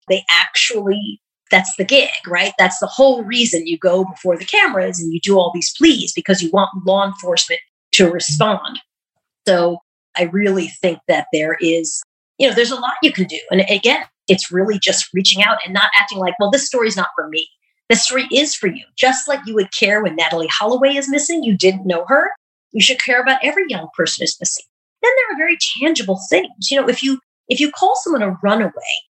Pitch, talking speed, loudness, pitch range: 205 Hz, 210 wpm, -15 LUFS, 185-275 Hz